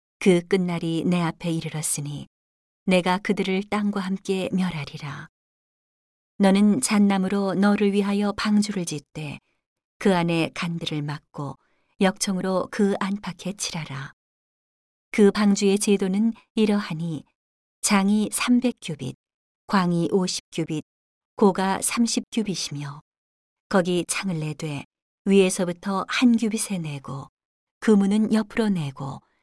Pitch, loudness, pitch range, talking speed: 190 Hz, -23 LUFS, 160-205 Hz, 225 characters per minute